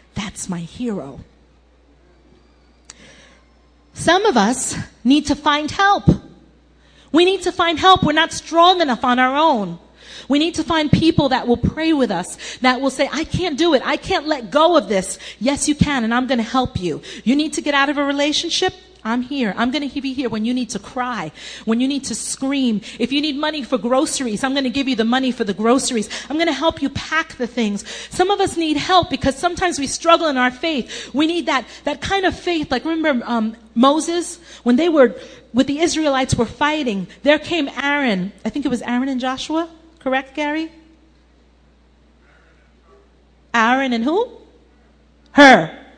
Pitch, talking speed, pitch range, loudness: 270 Hz, 195 wpm, 230-315 Hz, -18 LUFS